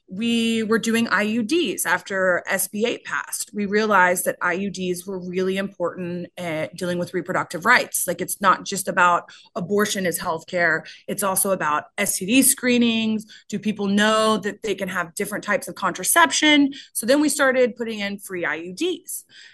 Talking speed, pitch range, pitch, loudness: 160 wpm, 180-230 Hz, 200 Hz, -21 LUFS